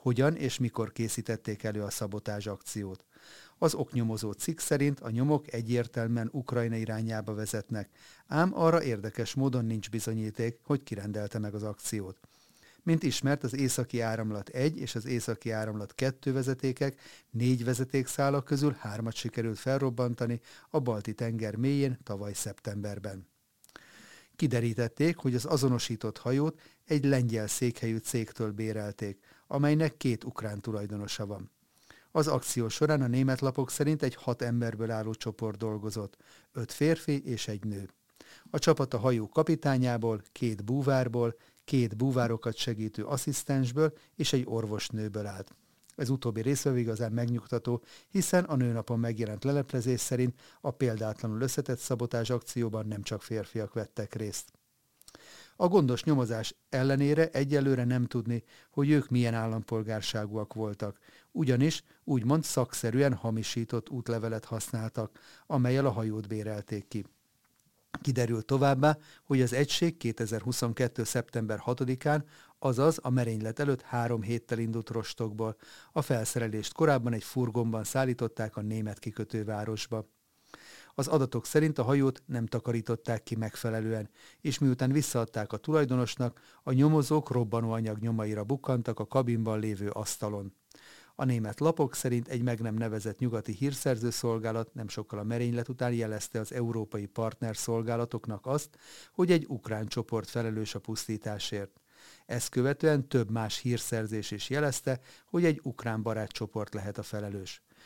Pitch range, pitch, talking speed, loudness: 110-135 Hz, 120 Hz, 130 wpm, -31 LUFS